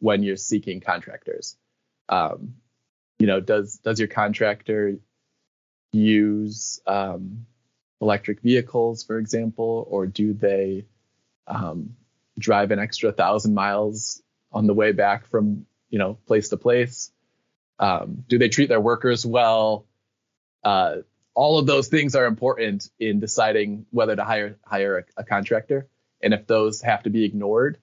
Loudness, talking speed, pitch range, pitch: -22 LUFS, 140 wpm, 105-120 Hz, 110 Hz